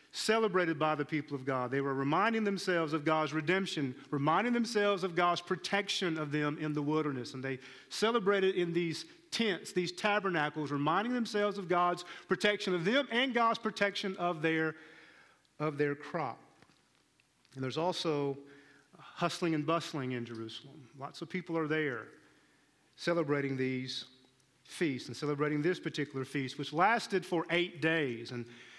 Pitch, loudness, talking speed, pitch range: 160 Hz, -33 LUFS, 150 wpm, 145-185 Hz